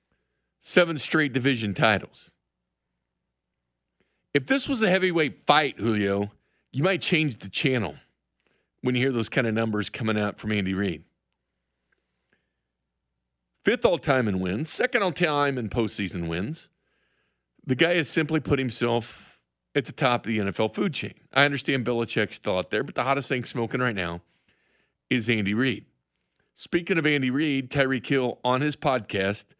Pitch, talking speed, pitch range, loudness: 120 Hz, 155 wpm, 90-145 Hz, -25 LUFS